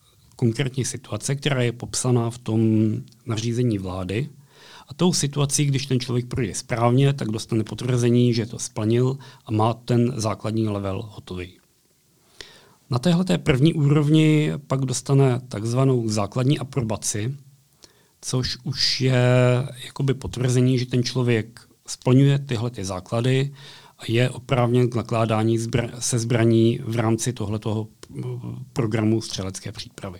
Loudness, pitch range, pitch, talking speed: -22 LUFS, 115-135 Hz, 120 Hz, 125 wpm